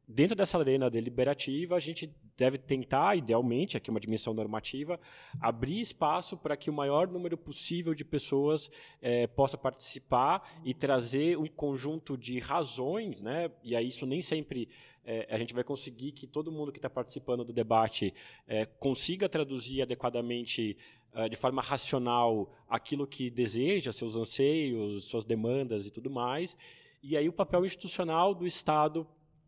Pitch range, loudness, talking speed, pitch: 120-155 Hz, -33 LUFS, 155 wpm, 135 Hz